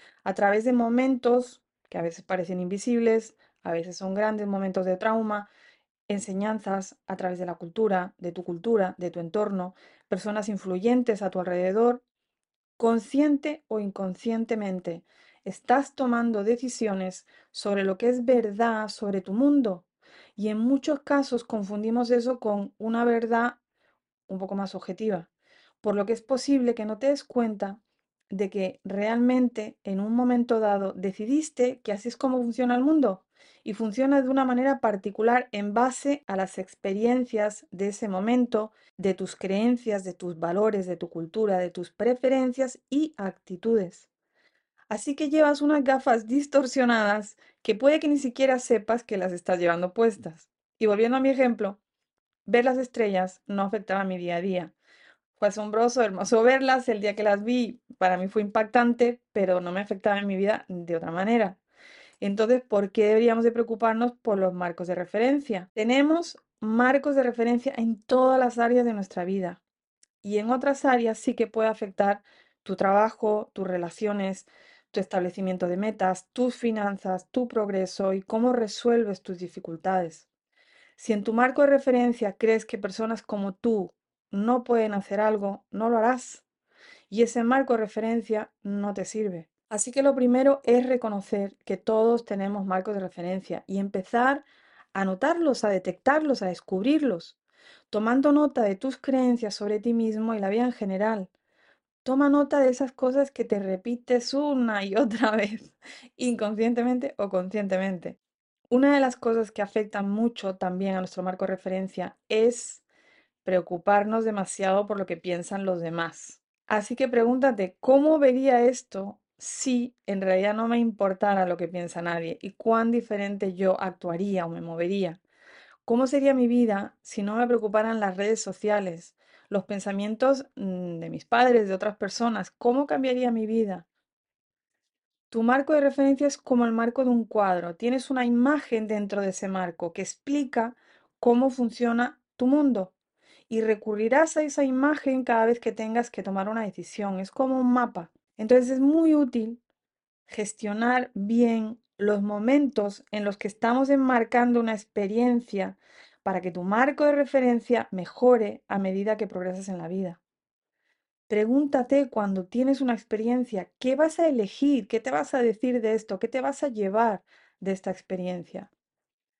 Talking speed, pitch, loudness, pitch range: 160 wpm, 220 Hz, -26 LUFS, 195-250 Hz